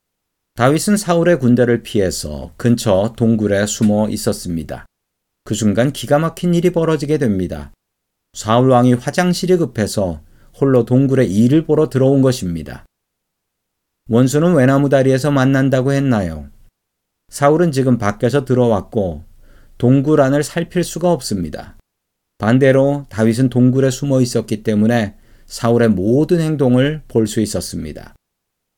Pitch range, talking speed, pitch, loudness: 110-145 Hz, 290 characters per minute, 125 Hz, -15 LUFS